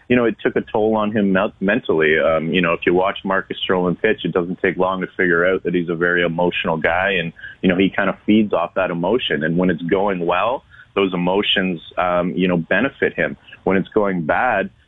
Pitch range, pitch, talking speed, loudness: 90-100 Hz, 90 Hz, 230 wpm, -18 LUFS